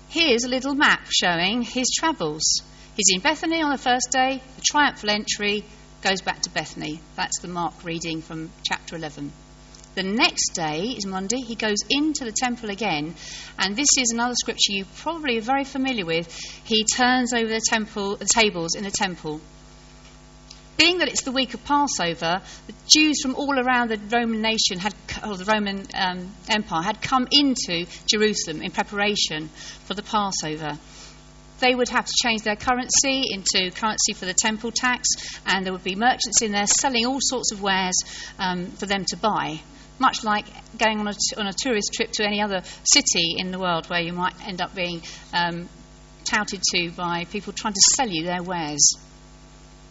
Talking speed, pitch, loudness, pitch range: 185 wpm, 205 Hz, -22 LUFS, 175-240 Hz